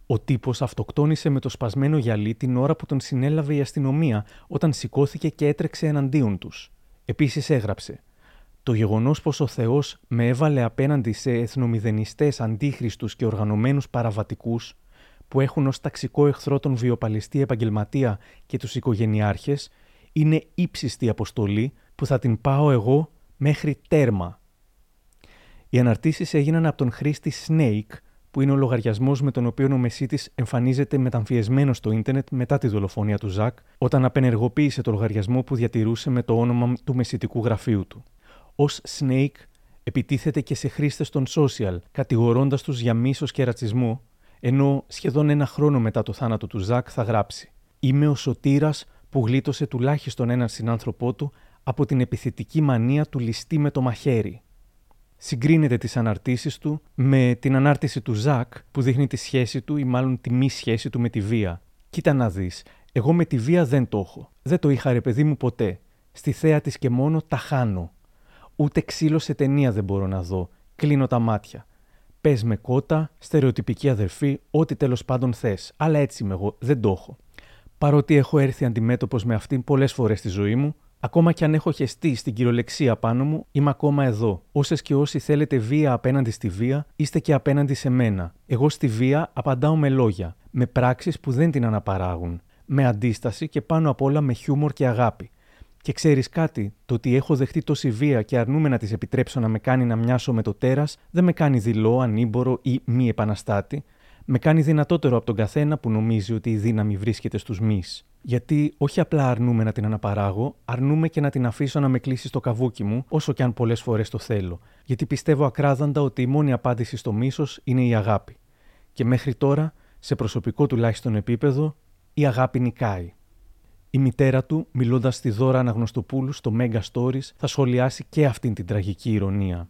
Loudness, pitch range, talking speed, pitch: -23 LUFS, 115-145 Hz, 175 wpm, 130 Hz